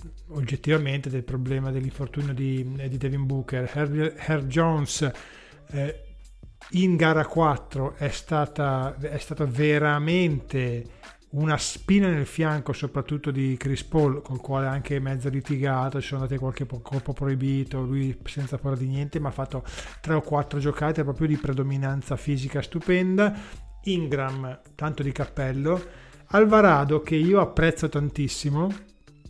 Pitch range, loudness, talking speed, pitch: 135-155 Hz, -25 LUFS, 135 wpm, 140 Hz